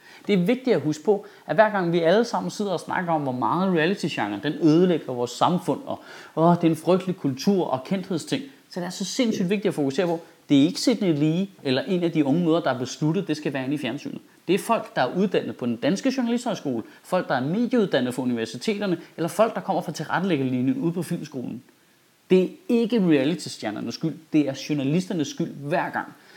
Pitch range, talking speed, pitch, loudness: 145-195 Hz, 225 wpm, 170 Hz, -24 LUFS